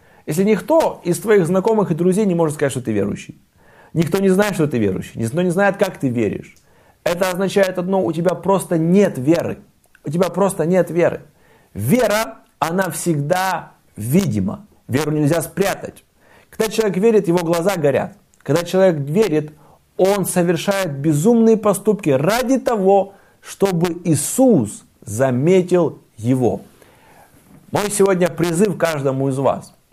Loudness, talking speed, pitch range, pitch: -18 LUFS, 140 wpm, 155-195 Hz, 180 Hz